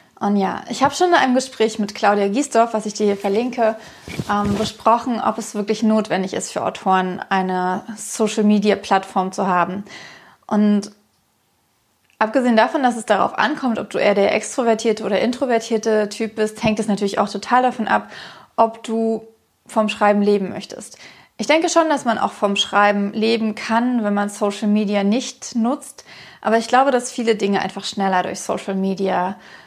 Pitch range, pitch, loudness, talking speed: 205-230 Hz, 215 Hz, -19 LUFS, 175 wpm